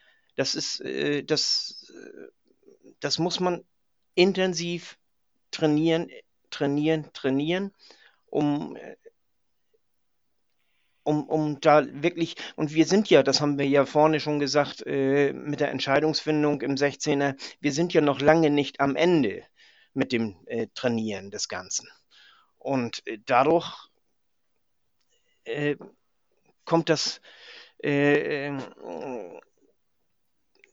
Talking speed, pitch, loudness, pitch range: 95 wpm, 150 Hz, -25 LUFS, 140-180 Hz